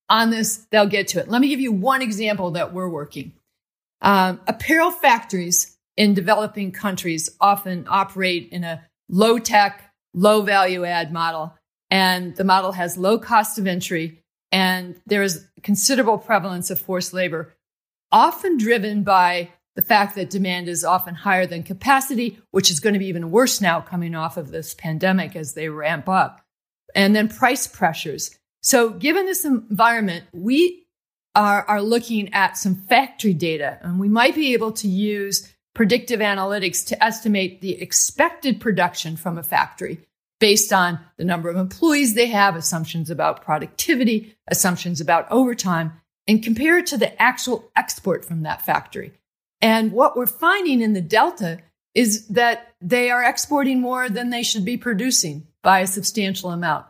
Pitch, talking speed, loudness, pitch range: 200 Hz, 165 wpm, -19 LUFS, 175-230 Hz